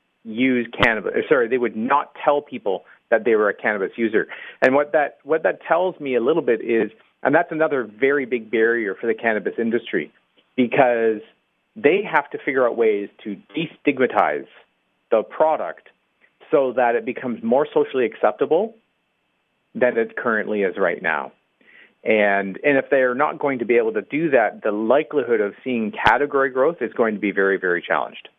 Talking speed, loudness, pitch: 180 wpm, -20 LUFS, 130 Hz